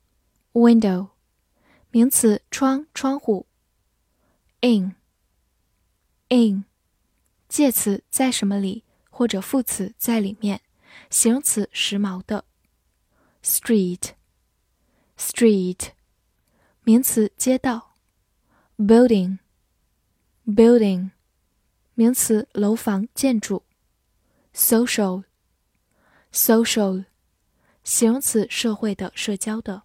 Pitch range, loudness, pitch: 190-235 Hz, -20 LUFS, 215 Hz